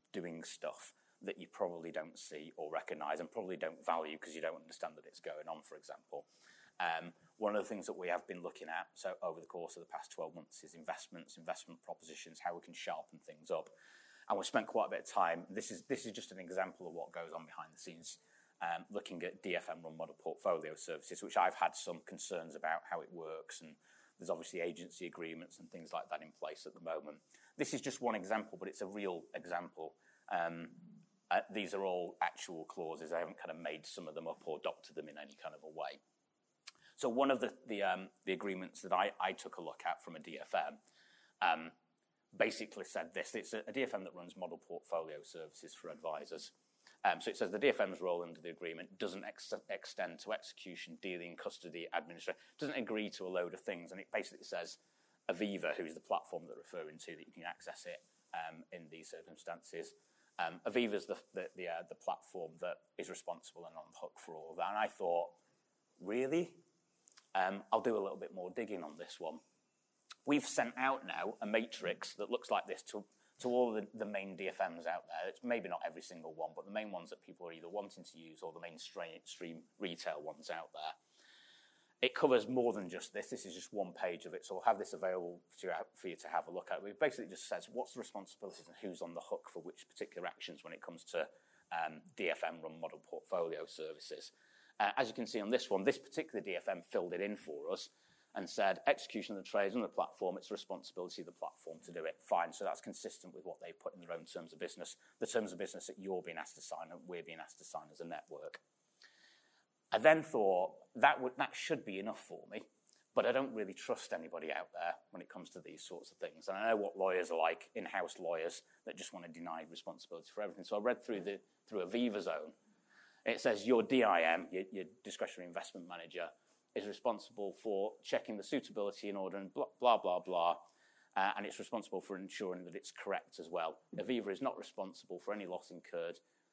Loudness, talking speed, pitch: -41 LUFS, 225 wpm, 120 Hz